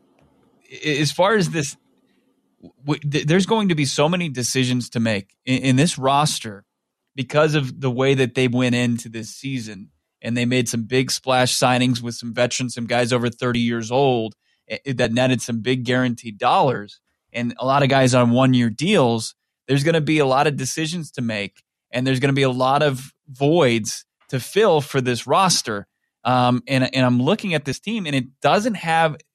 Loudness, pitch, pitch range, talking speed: -20 LUFS, 130 Hz, 120-145 Hz, 190 wpm